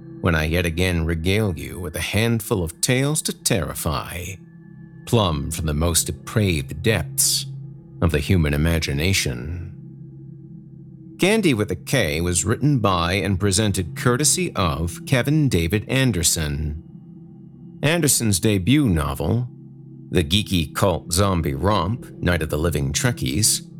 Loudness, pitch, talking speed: -21 LUFS, 105 Hz, 125 wpm